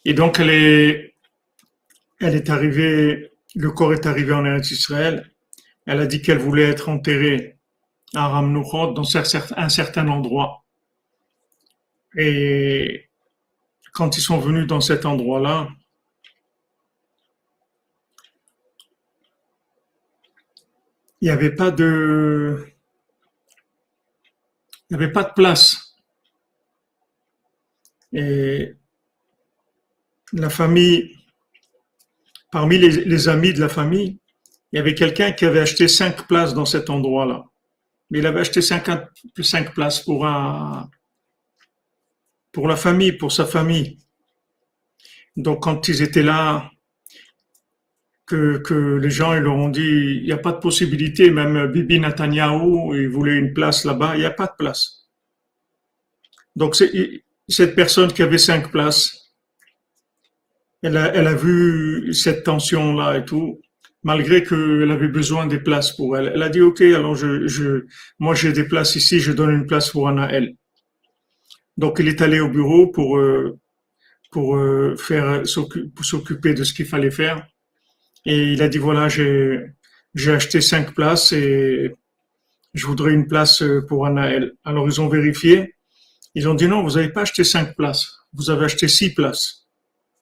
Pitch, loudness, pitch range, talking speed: 155 Hz, -17 LUFS, 145-165 Hz, 140 wpm